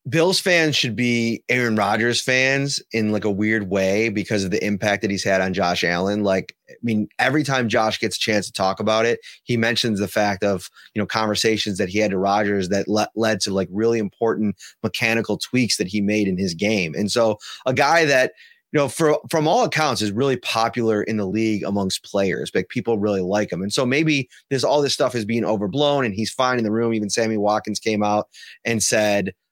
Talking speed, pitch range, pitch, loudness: 225 wpm, 105-125 Hz, 110 Hz, -20 LUFS